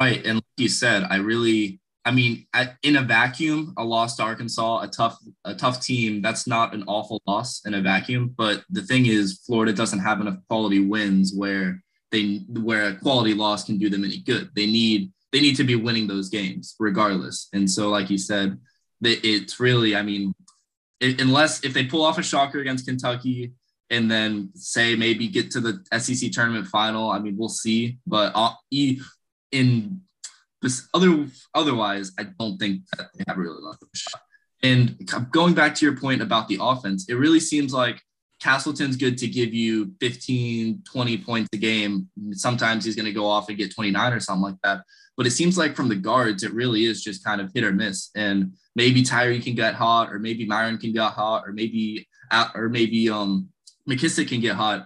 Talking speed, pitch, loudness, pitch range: 195 wpm, 115 Hz, -22 LUFS, 105-125 Hz